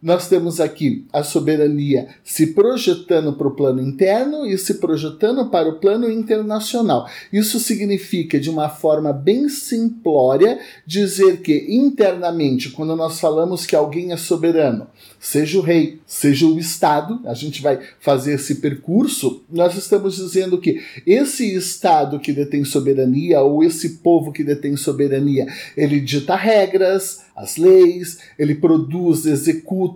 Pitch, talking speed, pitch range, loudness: 165 Hz, 140 wpm, 150-195 Hz, -17 LUFS